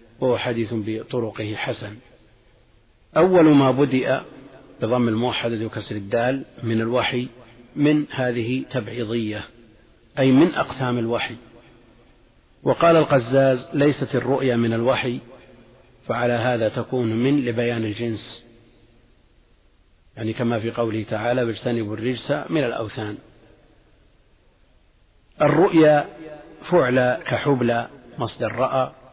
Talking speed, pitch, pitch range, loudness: 95 wpm, 120 Hz, 115-130 Hz, -21 LUFS